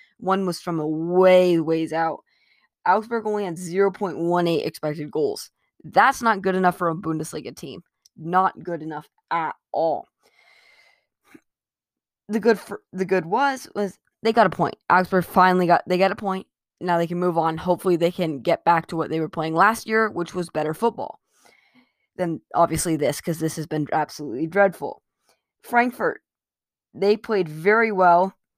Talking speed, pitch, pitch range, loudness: 170 wpm, 180 Hz, 165-210 Hz, -22 LUFS